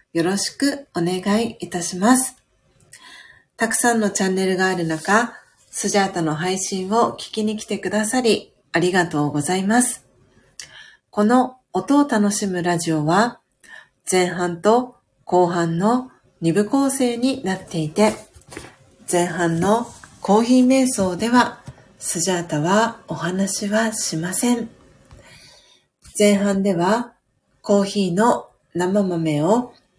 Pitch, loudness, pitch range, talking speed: 200 Hz, -20 LUFS, 180-230 Hz, 235 characters per minute